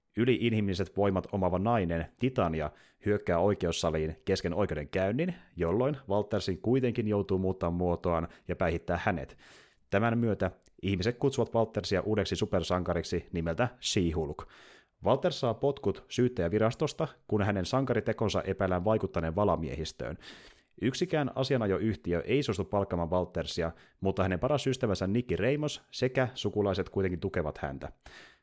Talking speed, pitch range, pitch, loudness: 120 wpm, 85-115 Hz, 100 Hz, -31 LUFS